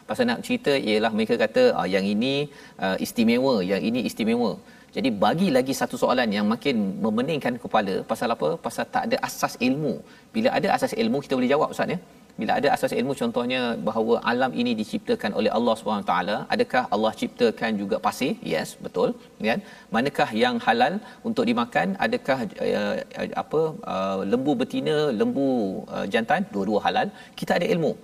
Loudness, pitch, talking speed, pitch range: -24 LUFS, 245 Hz, 170 wpm, 220-250 Hz